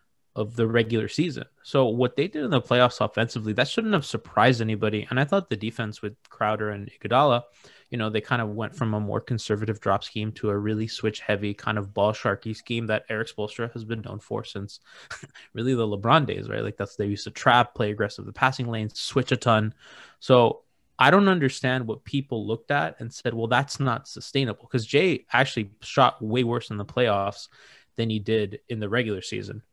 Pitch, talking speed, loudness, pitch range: 115 Hz, 210 wpm, -25 LUFS, 105-125 Hz